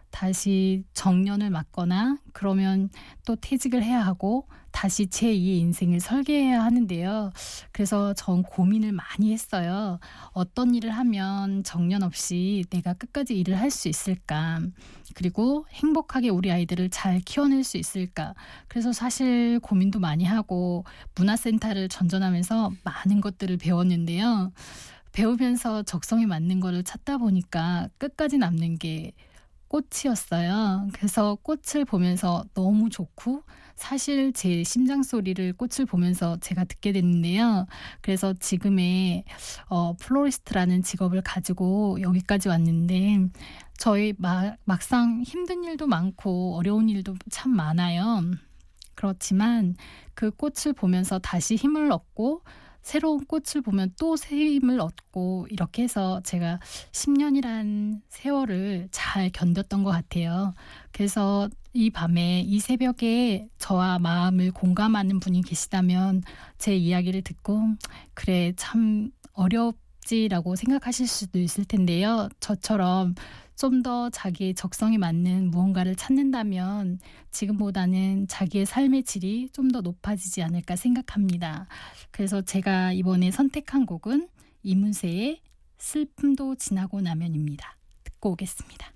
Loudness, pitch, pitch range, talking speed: -25 LUFS, 195 Hz, 180-235 Hz, 275 characters per minute